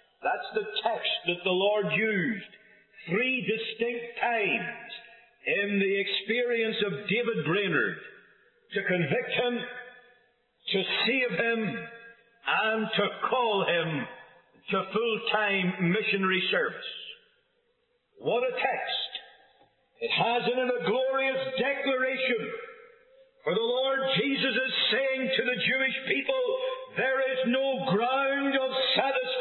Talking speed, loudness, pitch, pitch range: 115 wpm, -28 LUFS, 245 Hz, 220-265 Hz